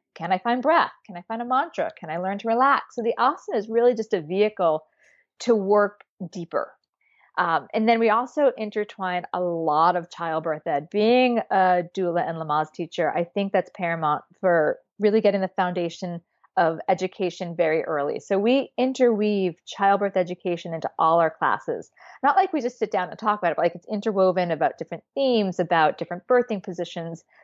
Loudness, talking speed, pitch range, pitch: -23 LUFS, 190 wpm, 170-220 Hz, 190 Hz